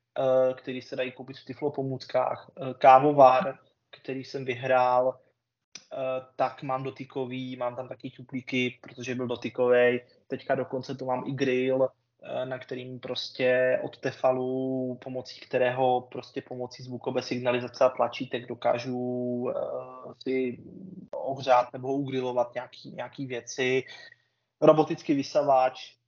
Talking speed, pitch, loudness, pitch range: 115 wpm, 130 Hz, -27 LUFS, 125-130 Hz